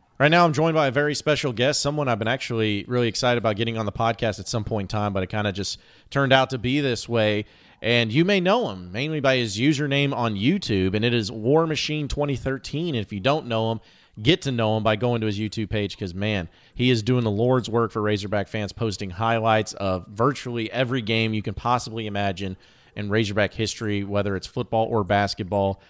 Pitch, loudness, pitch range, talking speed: 115 Hz, -23 LUFS, 105-130 Hz, 225 wpm